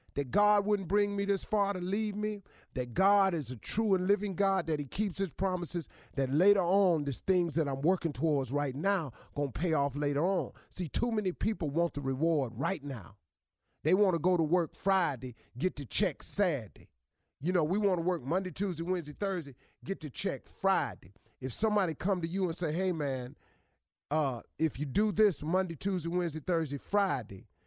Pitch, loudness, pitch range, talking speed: 175 Hz, -31 LUFS, 140-195 Hz, 200 wpm